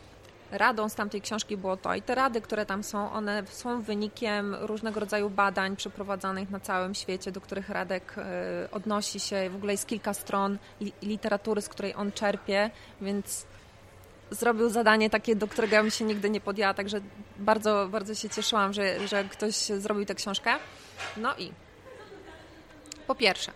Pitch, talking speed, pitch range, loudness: 205 Hz, 165 wpm, 195-215 Hz, -29 LUFS